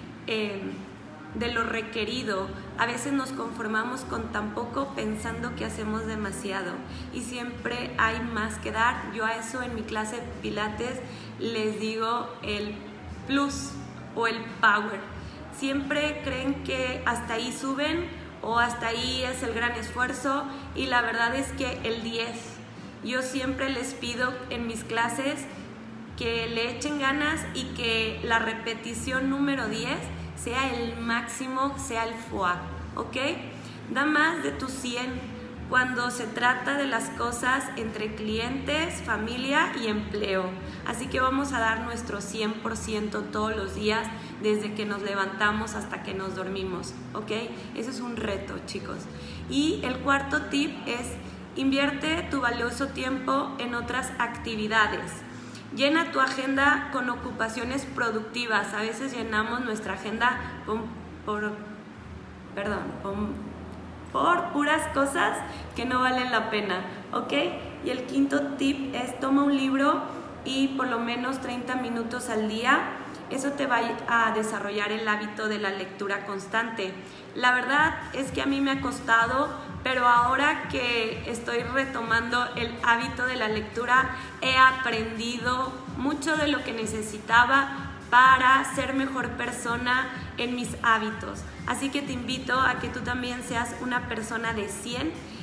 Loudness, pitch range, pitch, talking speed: -27 LUFS, 225-265 Hz, 240 Hz, 145 wpm